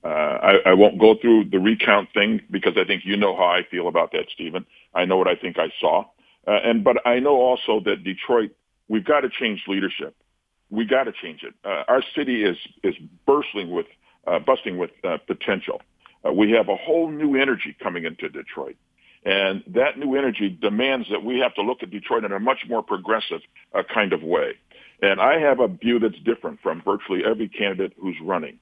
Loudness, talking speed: -21 LUFS, 210 wpm